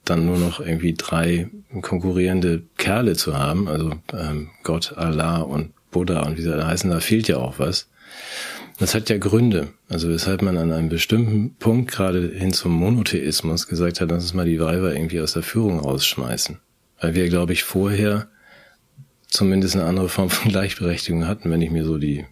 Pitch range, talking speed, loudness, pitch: 80-95 Hz, 185 wpm, -21 LUFS, 85 Hz